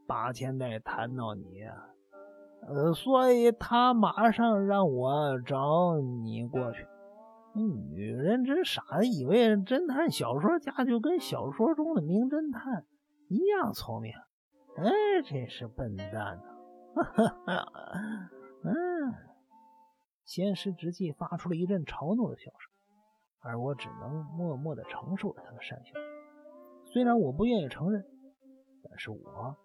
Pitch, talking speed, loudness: 195 Hz, 190 characters per minute, -30 LUFS